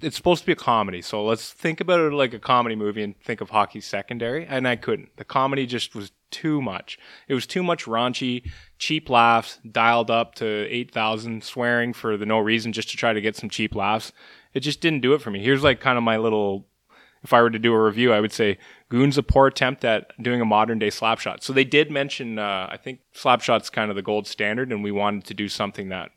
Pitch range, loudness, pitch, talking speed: 110-135 Hz, -22 LUFS, 115 Hz, 250 wpm